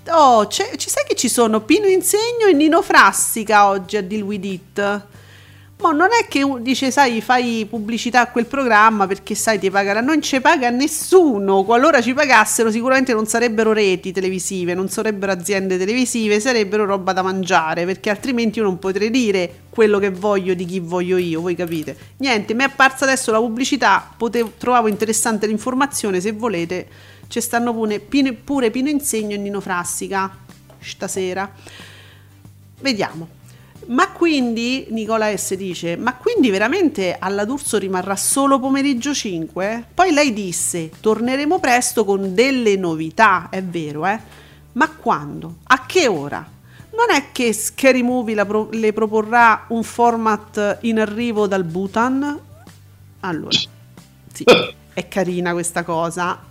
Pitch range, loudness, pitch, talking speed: 190-250 Hz, -17 LUFS, 220 Hz, 145 wpm